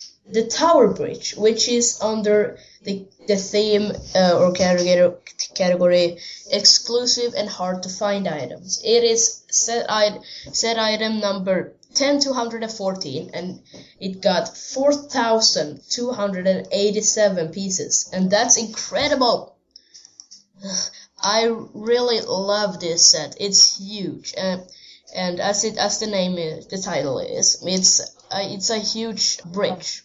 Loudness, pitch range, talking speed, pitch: -19 LUFS, 185-225 Hz, 120 wpm, 205 Hz